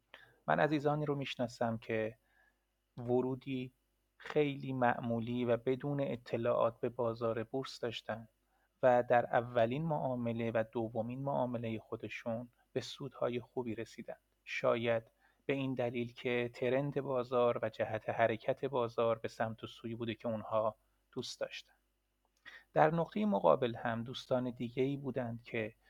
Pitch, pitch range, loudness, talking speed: 120 Hz, 115-130 Hz, -36 LUFS, 125 wpm